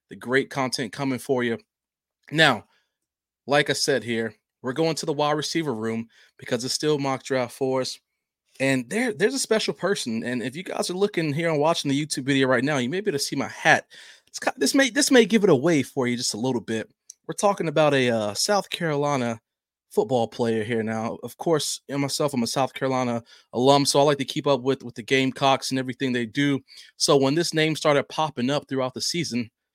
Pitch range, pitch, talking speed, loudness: 125-155 Hz, 135 Hz, 230 wpm, -23 LUFS